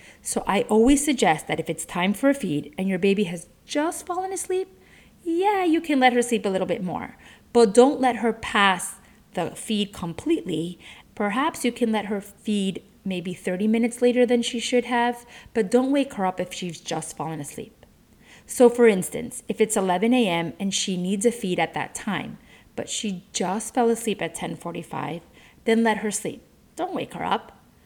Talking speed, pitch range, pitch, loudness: 195 wpm, 180-245 Hz, 215 Hz, -24 LUFS